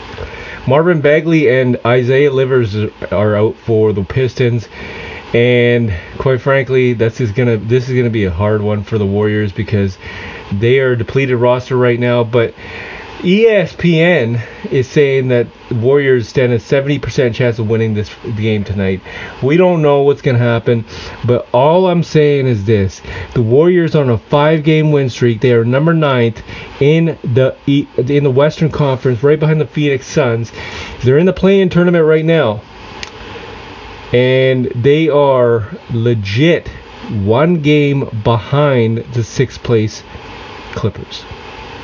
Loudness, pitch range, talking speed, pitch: -13 LUFS, 115-145 Hz, 155 wpm, 125 Hz